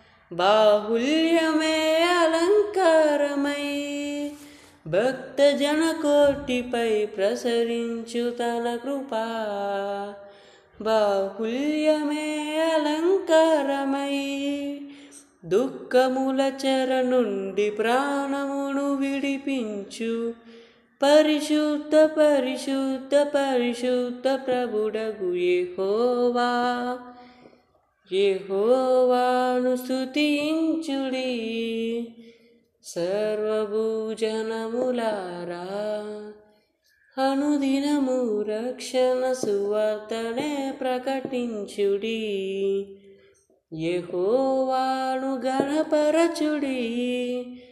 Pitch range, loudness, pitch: 225-285 Hz, -24 LUFS, 255 Hz